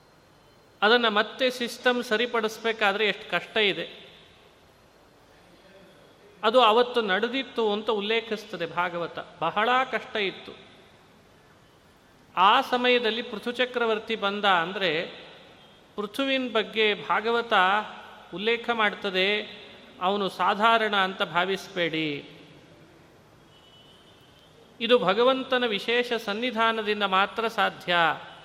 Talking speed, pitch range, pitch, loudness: 80 wpm, 190-235 Hz, 215 Hz, -25 LUFS